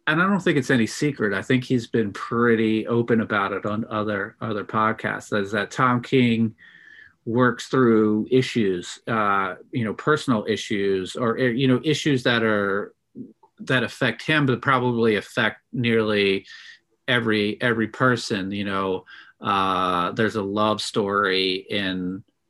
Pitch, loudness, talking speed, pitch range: 115 Hz, -22 LUFS, 150 wpm, 105-125 Hz